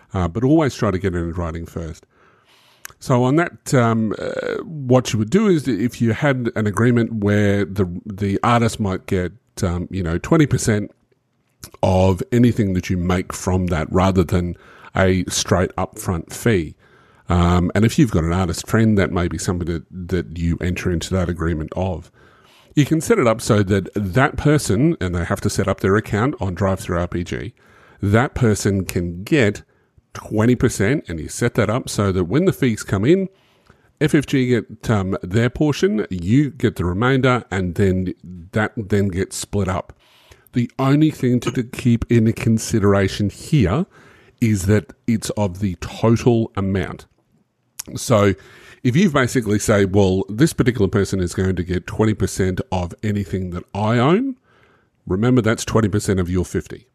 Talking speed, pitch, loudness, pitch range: 170 wpm, 105 Hz, -19 LUFS, 95-125 Hz